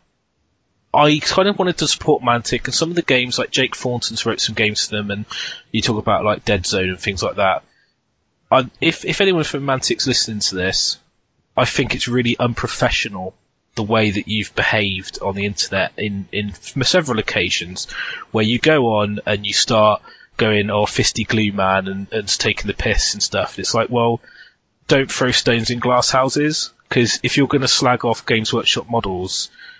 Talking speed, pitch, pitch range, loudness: 195 wpm, 115 Hz, 105-130 Hz, -18 LUFS